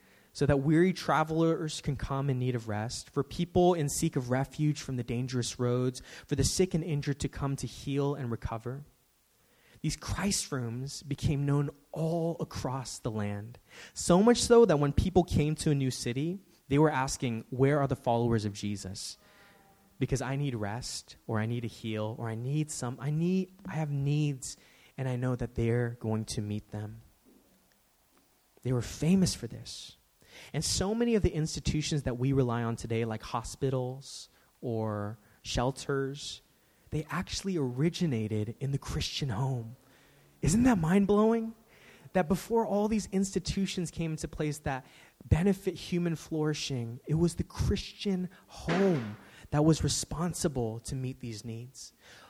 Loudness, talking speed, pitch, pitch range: -31 LUFS, 165 wpm, 140 Hz, 120-165 Hz